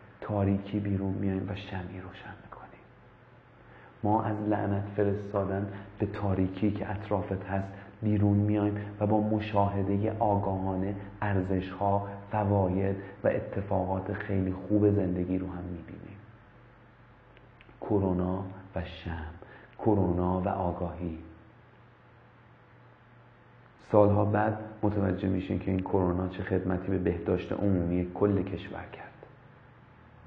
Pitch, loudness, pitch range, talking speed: 100 Hz, -30 LUFS, 95-105 Hz, 105 wpm